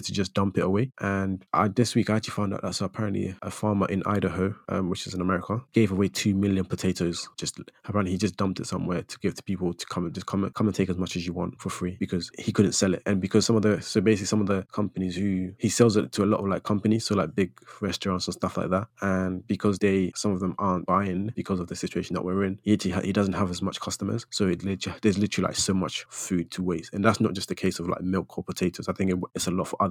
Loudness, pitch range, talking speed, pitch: -27 LUFS, 95-105 Hz, 285 wpm, 95 Hz